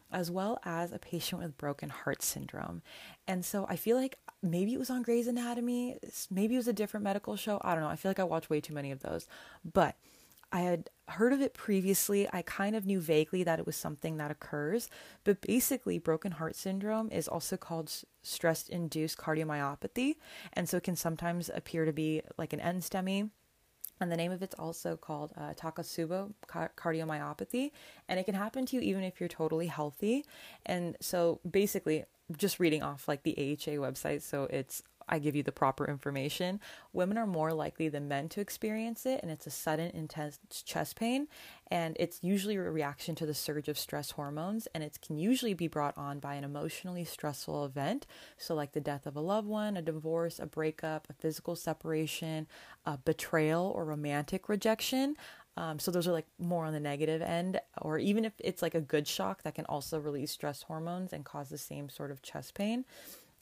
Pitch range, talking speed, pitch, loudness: 155-200 Hz, 200 wpm, 170 Hz, -35 LUFS